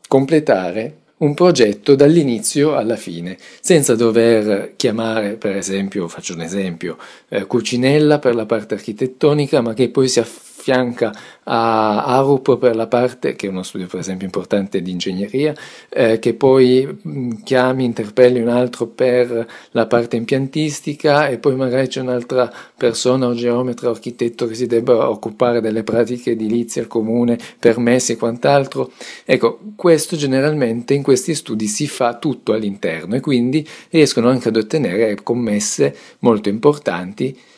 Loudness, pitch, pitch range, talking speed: -17 LUFS, 120 Hz, 115-135 Hz, 145 wpm